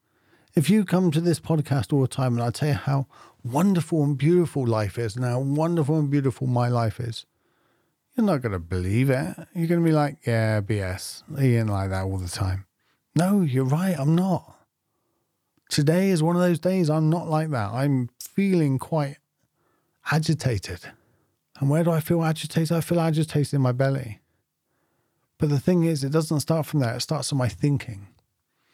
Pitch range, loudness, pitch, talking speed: 125-165 Hz, -24 LUFS, 145 Hz, 190 wpm